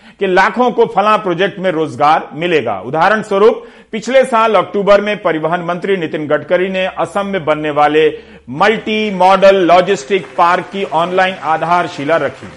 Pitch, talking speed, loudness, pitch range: 185 Hz, 150 wpm, -13 LUFS, 165-205 Hz